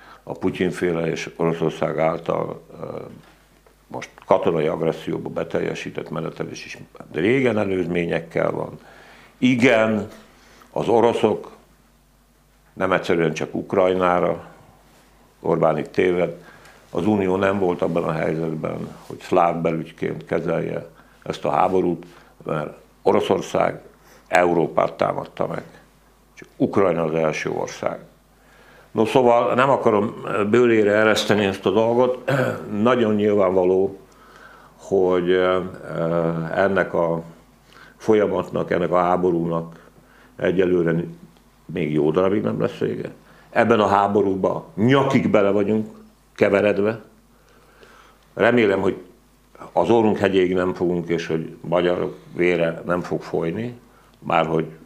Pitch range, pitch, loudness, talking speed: 85-105 Hz, 90 Hz, -21 LUFS, 105 wpm